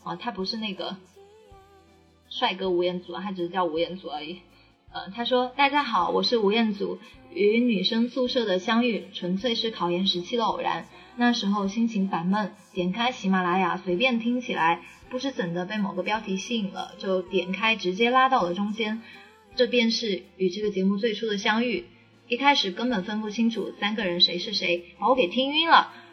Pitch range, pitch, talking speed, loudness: 185-240 Hz, 210 Hz, 285 characters per minute, -25 LUFS